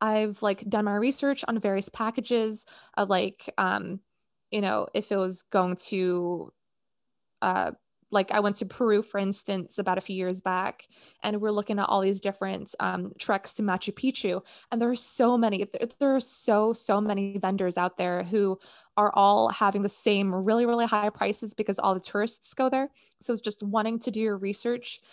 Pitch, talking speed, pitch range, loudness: 205 Hz, 190 wpm, 195-225 Hz, -27 LUFS